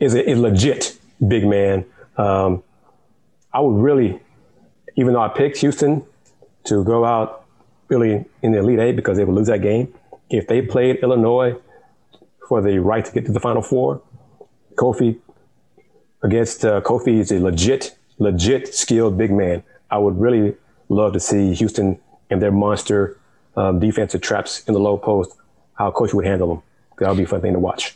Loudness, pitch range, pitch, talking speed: -18 LUFS, 100-120 Hz, 110 Hz, 180 wpm